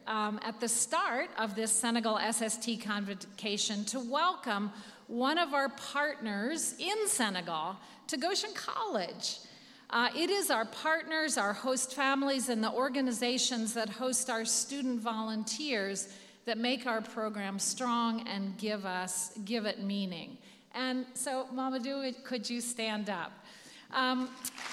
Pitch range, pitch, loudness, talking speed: 215-265 Hz, 235 Hz, -33 LUFS, 135 wpm